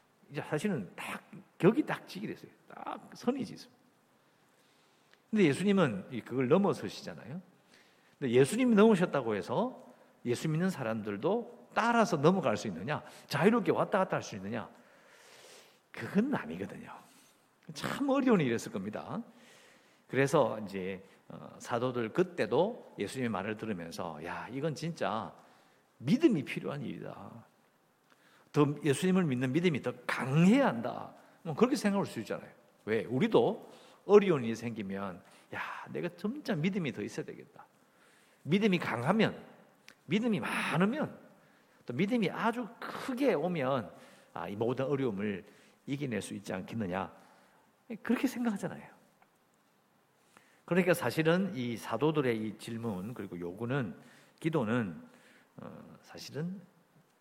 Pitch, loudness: 170 Hz, -32 LUFS